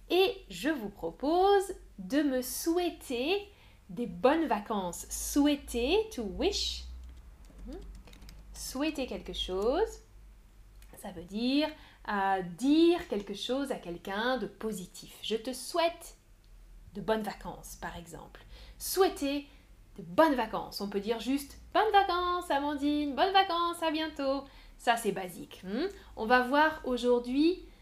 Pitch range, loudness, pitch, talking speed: 200-325 Hz, -31 LUFS, 260 Hz, 125 wpm